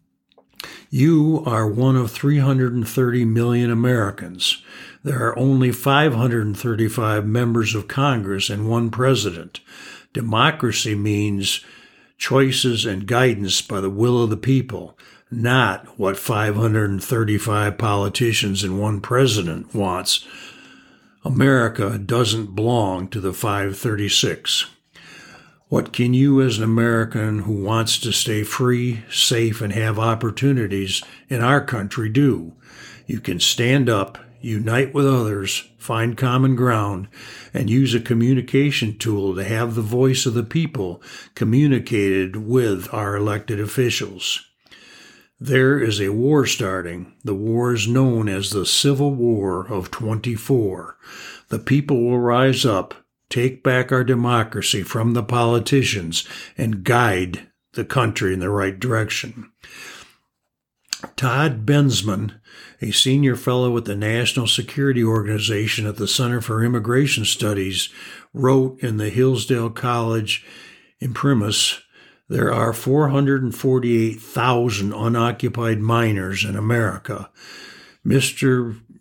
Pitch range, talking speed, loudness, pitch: 105-125 Hz, 115 wpm, -19 LUFS, 115 Hz